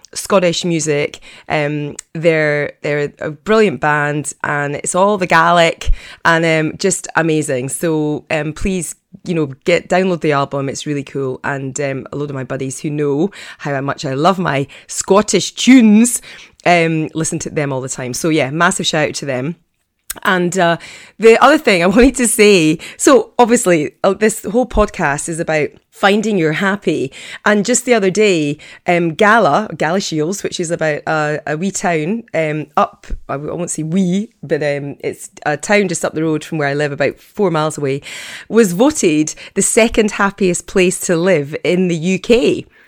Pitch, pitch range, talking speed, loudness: 170 Hz, 150-195 Hz, 180 wpm, -15 LUFS